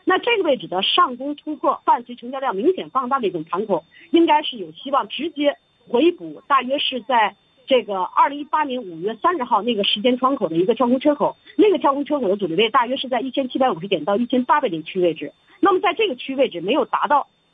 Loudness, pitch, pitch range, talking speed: -20 LUFS, 265 Hz, 215-305 Hz, 360 characters per minute